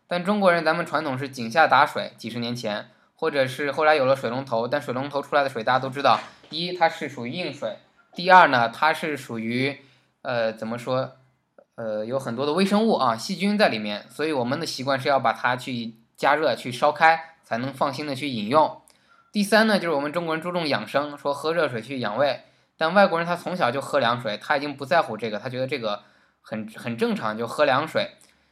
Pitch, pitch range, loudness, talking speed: 140 Hz, 120-165 Hz, -23 LUFS, 320 characters per minute